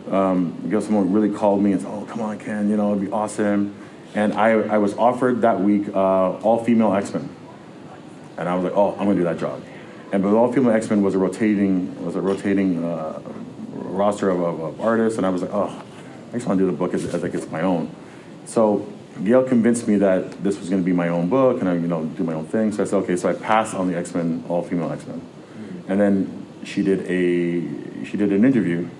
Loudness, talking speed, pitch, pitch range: -21 LUFS, 240 wpm, 100 Hz, 90-105 Hz